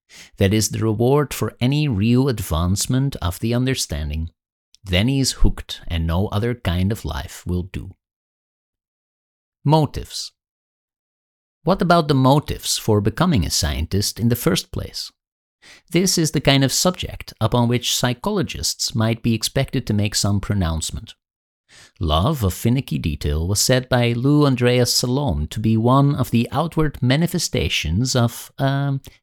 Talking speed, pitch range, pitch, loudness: 150 wpm, 90-130 Hz, 110 Hz, -20 LUFS